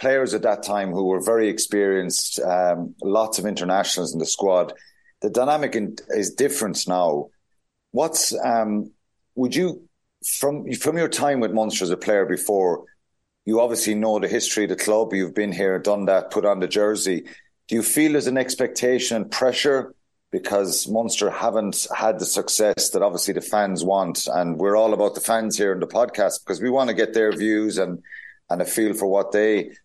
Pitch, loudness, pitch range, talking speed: 110 Hz, -21 LUFS, 100-125 Hz, 190 wpm